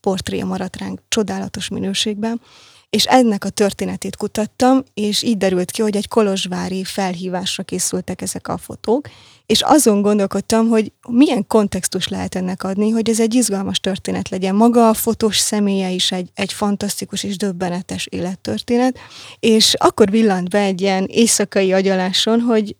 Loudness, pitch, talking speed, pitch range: -17 LUFS, 200 Hz, 150 wpm, 190-220 Hz